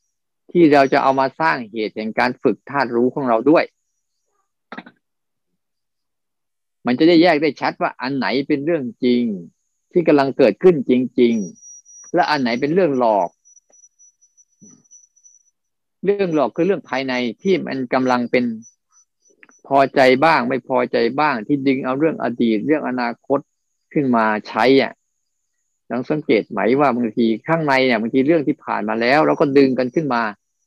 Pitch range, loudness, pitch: 120-155 Hz, -18 LUFS, 130 Hz